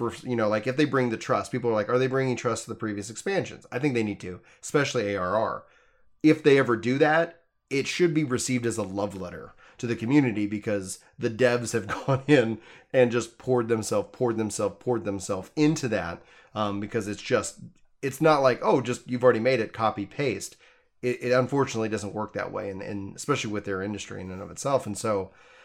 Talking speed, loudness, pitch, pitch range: 215 wpm, -26 LUFS, 120 Hz, 105-130 Hz